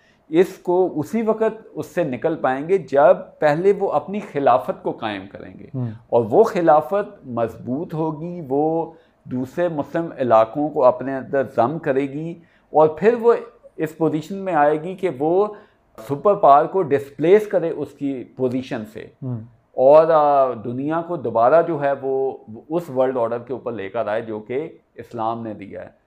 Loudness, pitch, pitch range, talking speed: -20 LUFS, 150 Hz, 125-175 Hz, 170 wpm